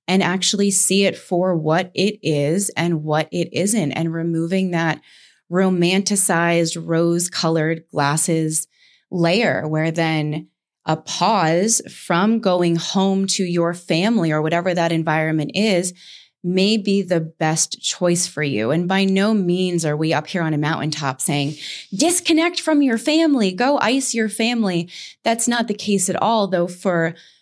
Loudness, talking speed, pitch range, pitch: -19 LUFS, 150 wpm, 165-200 Hz, 175 Hz